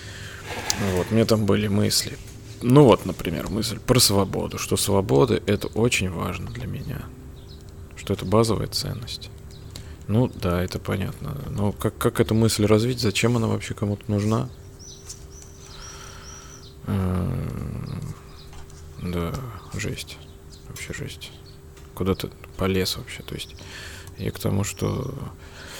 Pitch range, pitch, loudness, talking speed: 85-115 Hz, 100 Hz, -24 LUFS, 115 wpm